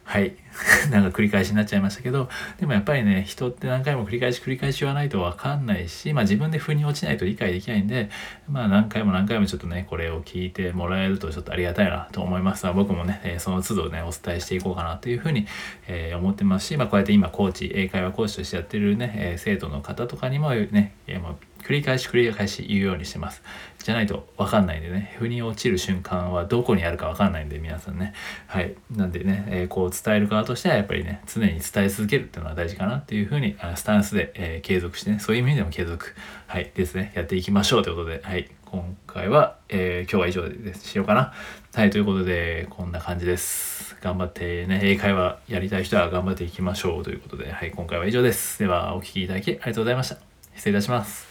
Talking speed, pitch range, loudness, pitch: 500 characters per minute, 90-105 Hz, -24 LUFS, 95 Hz